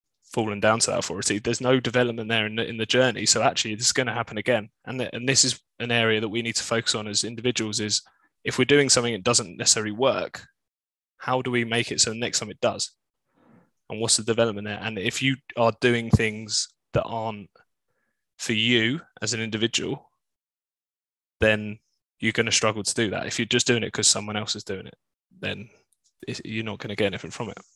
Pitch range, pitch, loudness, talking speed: 105-120 Hz, 115 Hz, -24 LUFS, 225 wpm